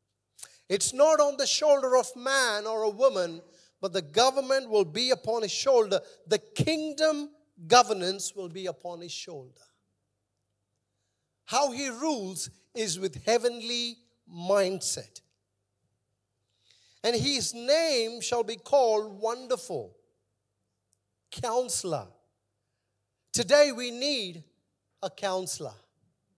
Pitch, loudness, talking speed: 195 Hz, -27 LUFS, 105 wpm